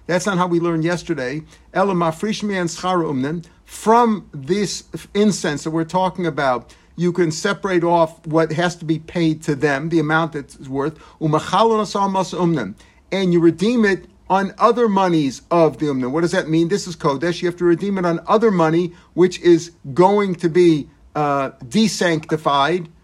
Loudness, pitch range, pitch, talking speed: -19 LUFS, 160-185 Hz, 175 Hz, 155 wpm